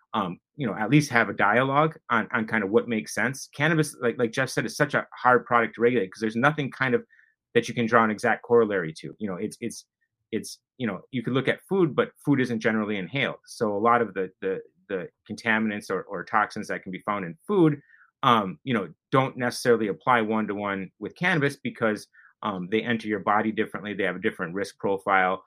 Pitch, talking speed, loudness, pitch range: 120 Hz, 225 wpm, -25 LUFS, 110-145 Hz